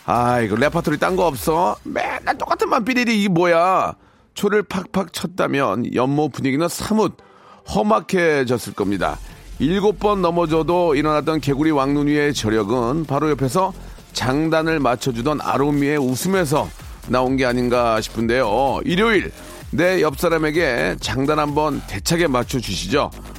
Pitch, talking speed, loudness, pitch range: 150 Hz, 305 characters per minute, -19 LUFS, 130-175 Hz